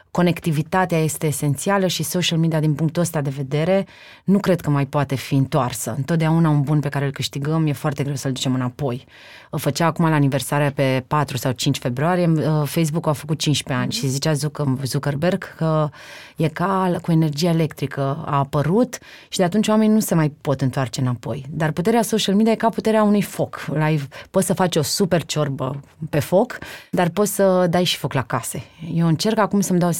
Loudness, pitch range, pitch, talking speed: -20 LUFS, 140-180 Hz, 155 Hz, 195 wpm